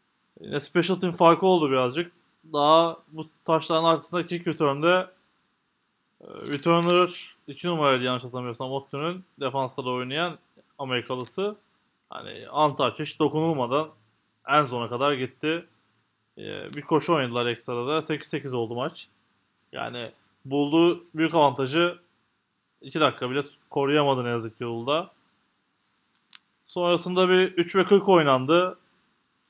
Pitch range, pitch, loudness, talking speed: 130-170 Hz, 155 Hz, -25 LUFS, 110 wpm